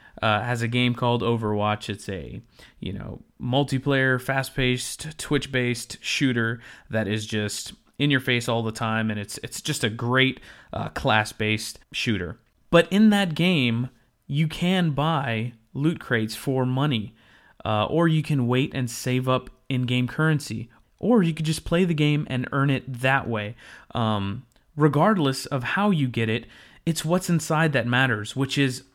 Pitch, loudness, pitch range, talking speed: 130 Hz, -24 LUFS, 115-145 Hz, 165 wpm